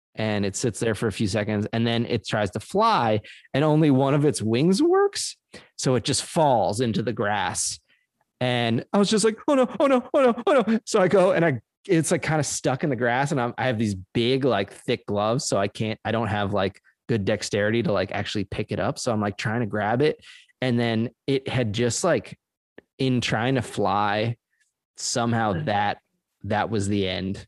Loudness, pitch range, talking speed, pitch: -24 LUFS, 105-150 Hz, 215 wpm, 120 Hz